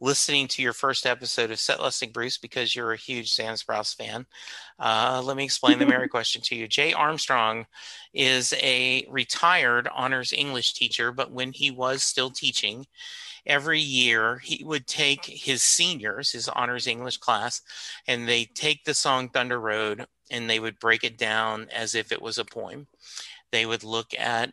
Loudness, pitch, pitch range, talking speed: -24 LUFS, 125 Hz, 115-140 Hz, 180 wpm